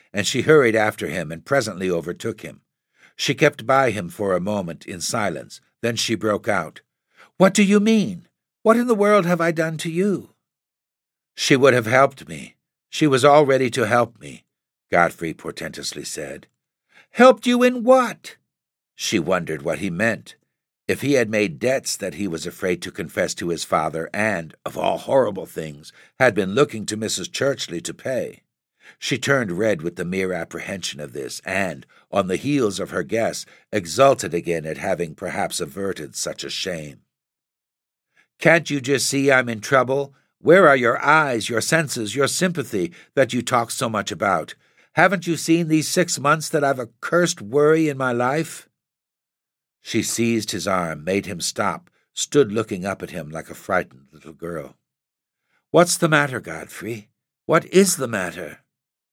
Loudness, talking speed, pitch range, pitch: -20 LUFS, 175 wpm, 105-160 Hz, 135 Hz